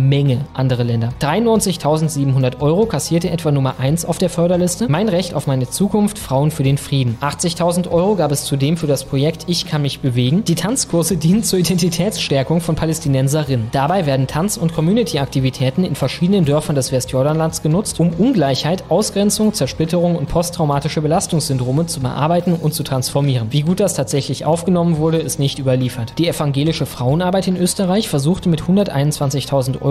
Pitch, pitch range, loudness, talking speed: 155 Hz, 140-175 Hz, -17 LUFS, 165 wpm